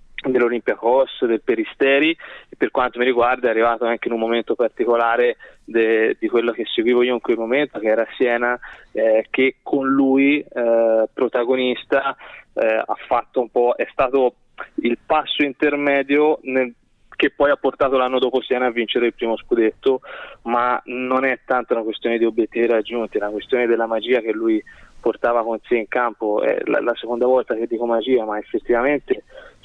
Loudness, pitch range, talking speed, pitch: -19 LUFS, 115-130 Hz, 175 wpm, 120 Hz